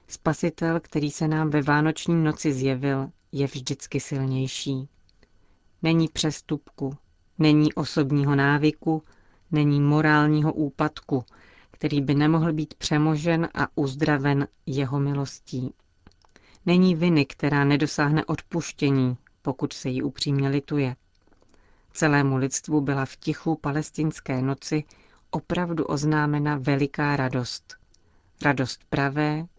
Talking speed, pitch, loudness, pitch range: 105 wpm, 145 Hz, -25 LUFS, 140-155 Hz